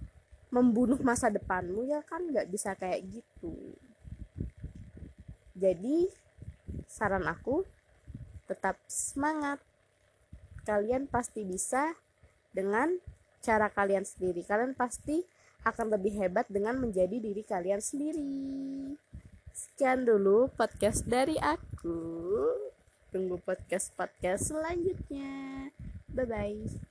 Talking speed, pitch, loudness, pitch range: 90 wpm, 235 Hz, -32 LUFS, 200-280 Hz